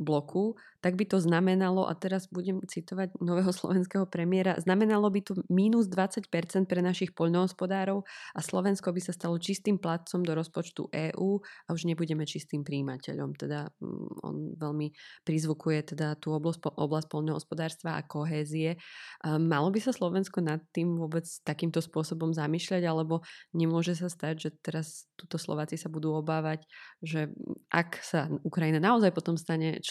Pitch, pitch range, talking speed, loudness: 165 Hz, 155-185 Hz, 150 wpm, -31 LUFS